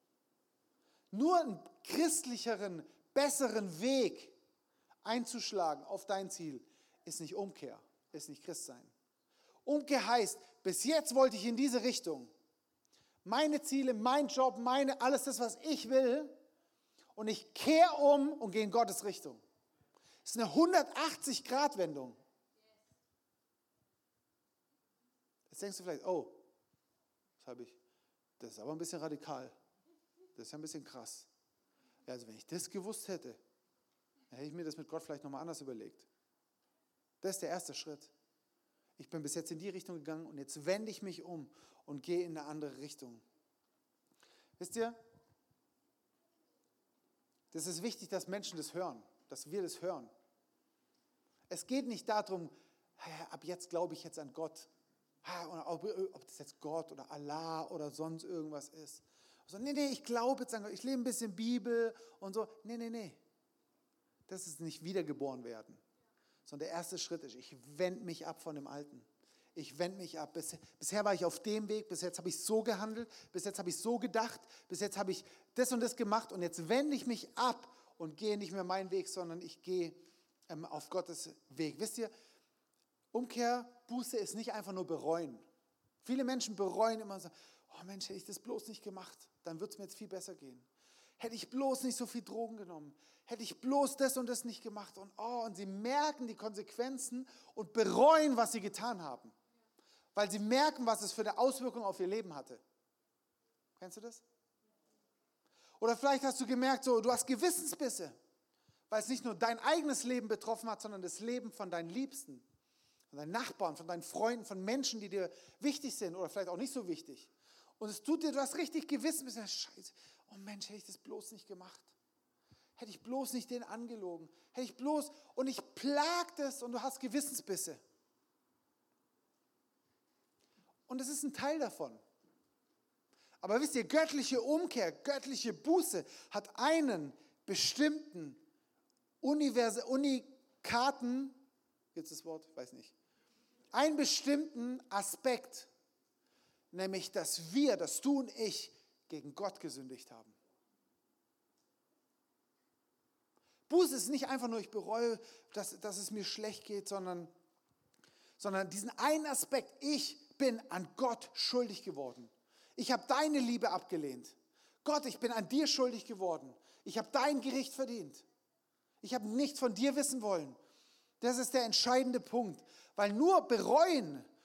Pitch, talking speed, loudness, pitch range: 225 Hz, 160 wpm, -37 LUFS, 180-265 Hz